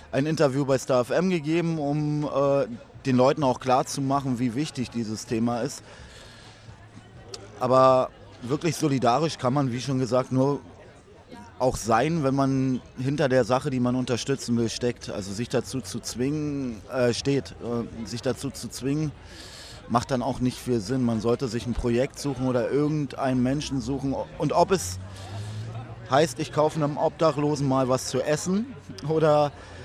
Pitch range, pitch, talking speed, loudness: 120-140 Hz, 130 Hz, 165 wpm, -25 LUFS